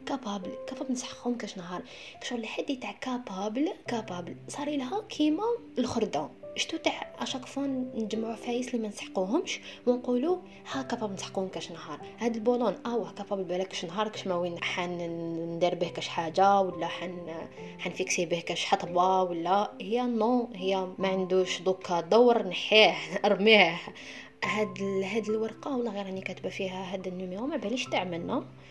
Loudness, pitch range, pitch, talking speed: -30 LUFS, 185-245 Hz, 200 Hz, 150 wpm